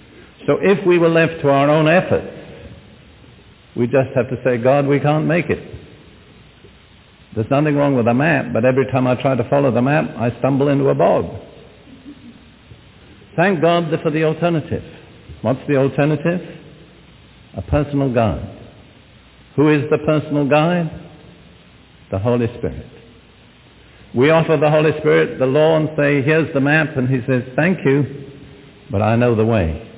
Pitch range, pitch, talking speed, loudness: 125-155 Hz, 140 Hz, 160 wpm, -17 LUFS